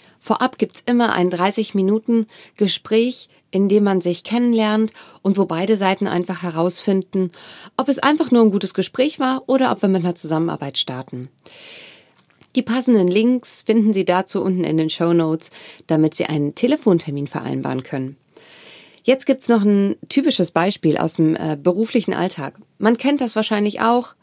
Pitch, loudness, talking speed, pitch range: 195 Hz, -19 LUFS, 160 wpm, 175-235 Hz